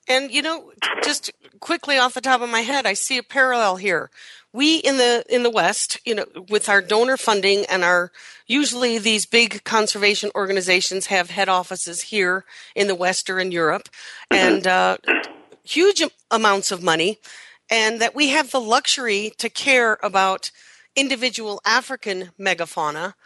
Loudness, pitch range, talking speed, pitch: -19 LUFS, 190-255 Hz, 165 wpm, 215 Hz